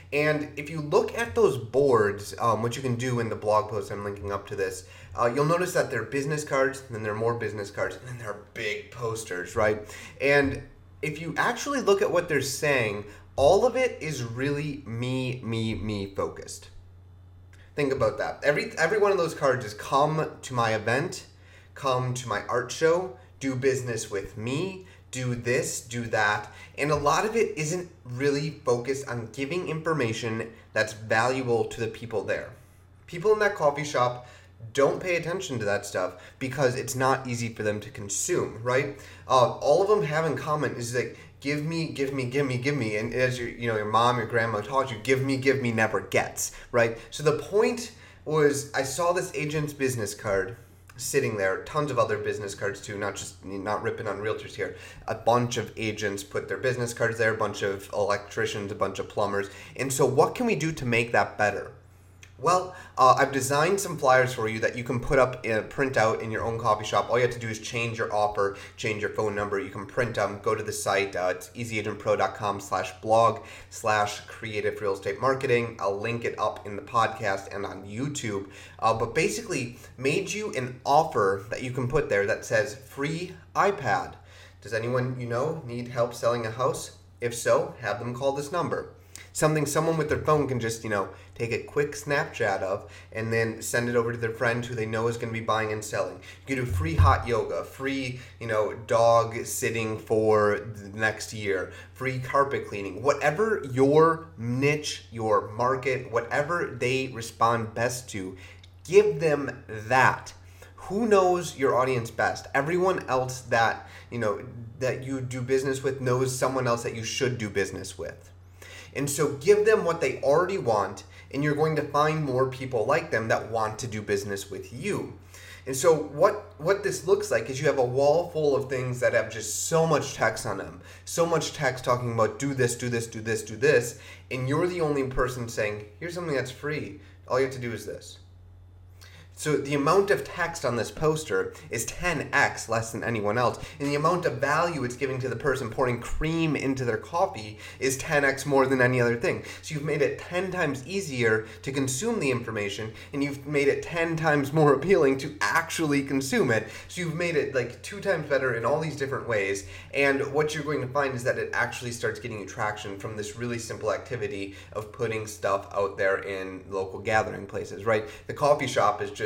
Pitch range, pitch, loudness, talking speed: 105-140 Hz, 120 Hz, -27 LUFS, 205 wpm